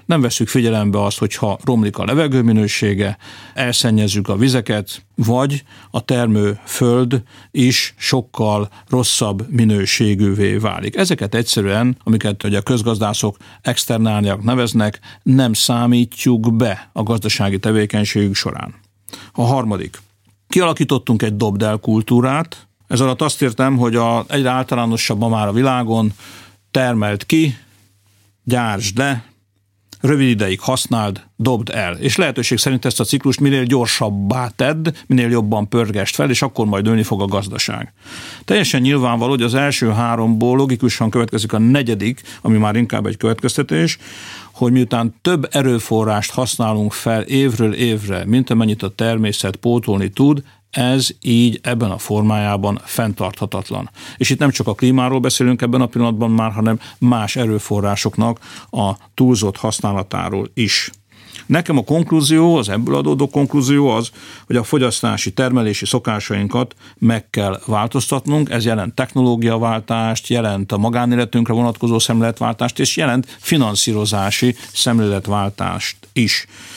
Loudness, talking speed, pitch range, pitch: -16 LUFS, 130 wpm, 105-125 Hz, 115 Hz